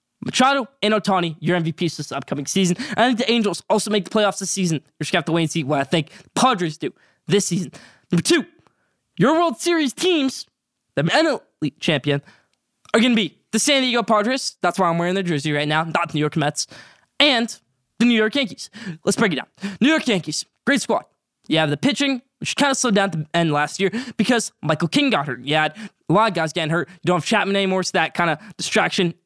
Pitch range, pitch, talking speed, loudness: 160-230 Hz, 190 Hz, 240 wpm, -20 LUFS